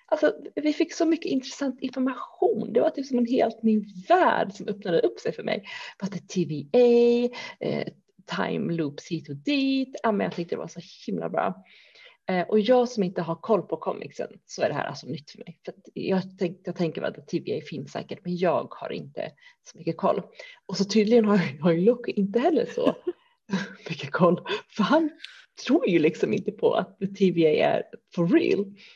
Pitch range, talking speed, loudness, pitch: 180-295 Hz, 195 wpm, -26 LUFS, 220 Hz